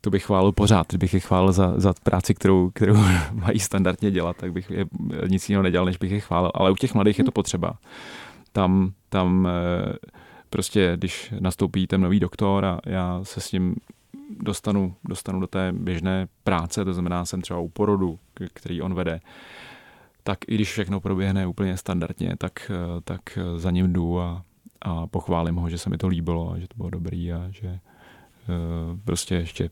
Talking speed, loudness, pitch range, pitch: 180 wpm, -24 LUFS, 90-100 Hz, 95 Hz